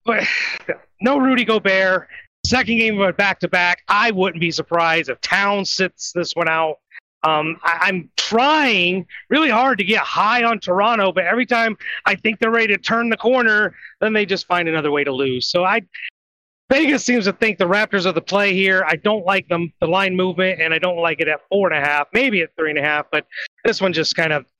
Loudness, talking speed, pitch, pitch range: -17 LUFS, 225 wpm, 190 Hz, 170-220 Hz